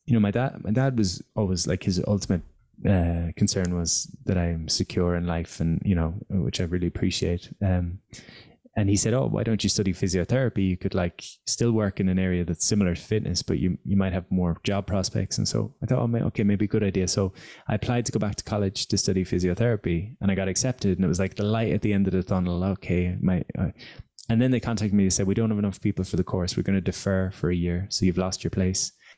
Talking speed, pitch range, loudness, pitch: 255 wpm, 90-110 Hz, -25 LUFS, 95 Hz